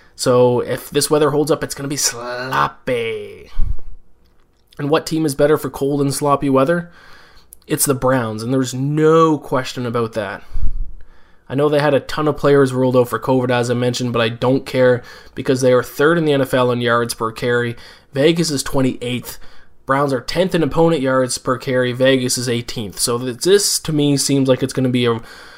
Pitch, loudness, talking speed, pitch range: 130 Hz, -17 LUFS, 200 wpm, 125-145 Hz